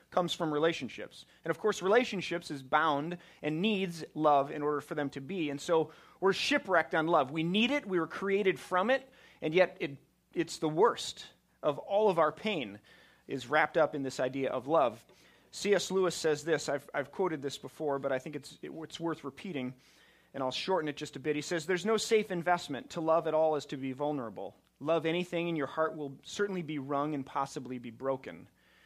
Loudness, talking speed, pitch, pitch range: -32 LUFS, 210 wpm, 160 Hz, 145-180 Hz